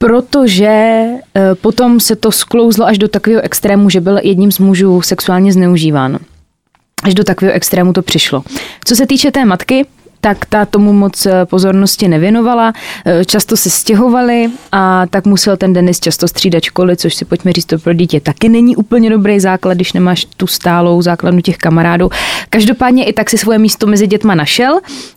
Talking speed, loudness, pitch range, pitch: 170 wpm, -9 LUFS, 180-225 Hz, 195 Hz